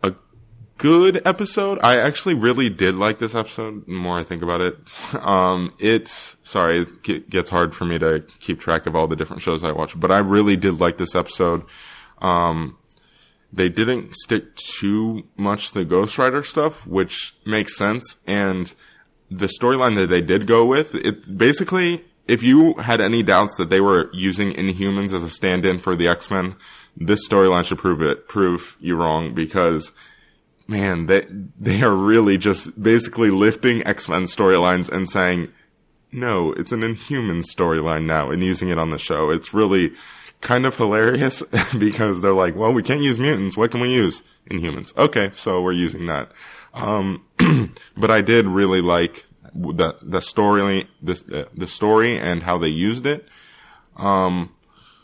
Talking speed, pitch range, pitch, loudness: 170 wpm, 90-115 Hz, 100 Hz, -19 LUFS